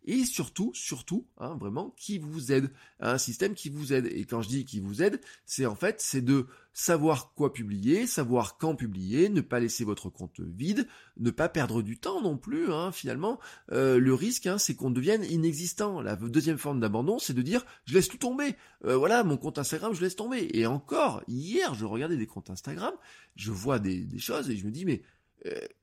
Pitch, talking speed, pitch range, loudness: 145 Hz, 215 wpm, 120-190 Hz, -30 LUFS